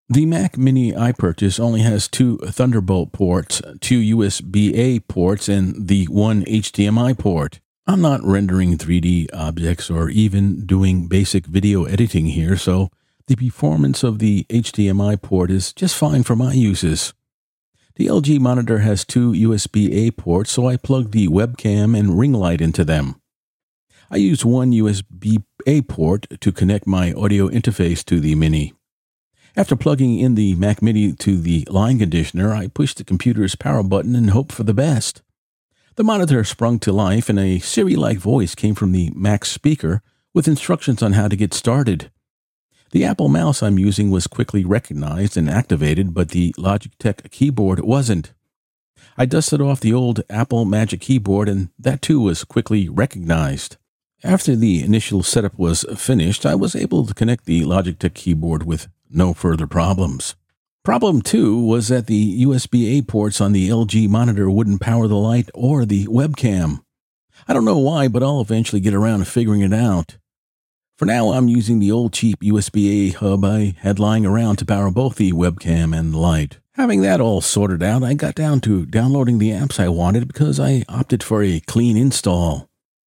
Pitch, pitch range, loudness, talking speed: 105 Hz, 95-120 Hz, -17 LUFS, 175 wpm